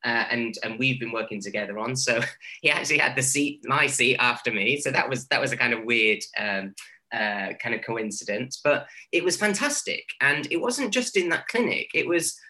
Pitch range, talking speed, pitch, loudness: 115-155 Hz, 225 wpm, 125 Hz, -24 LUFS